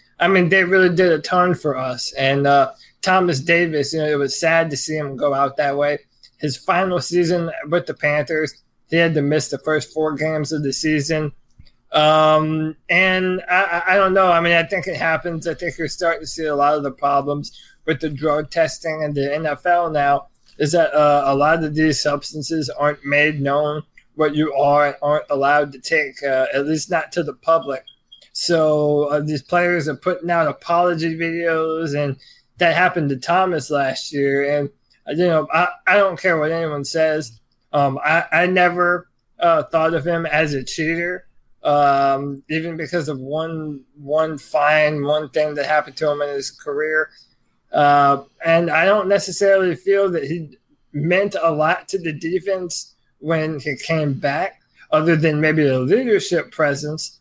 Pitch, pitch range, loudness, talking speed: 155 Hz, 145-170 Hz, -18 LUFS, 185 wpm